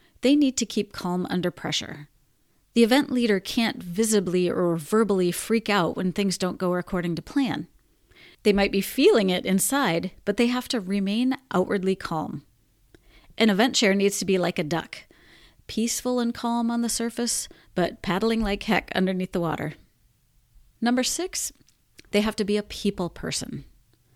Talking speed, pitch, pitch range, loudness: 165 wpm, 205 Hz, 180-235 Hz, -24 LUFS